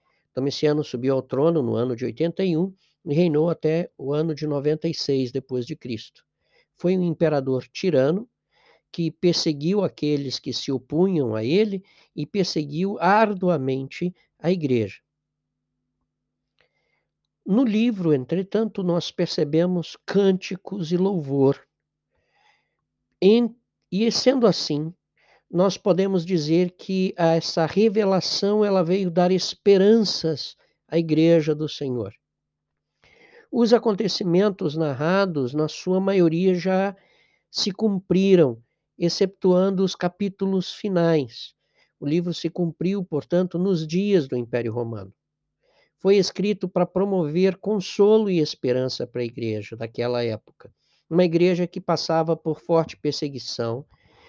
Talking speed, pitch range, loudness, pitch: 115 wpm, 145-190 Hz, -22 LUFS, 170 Hz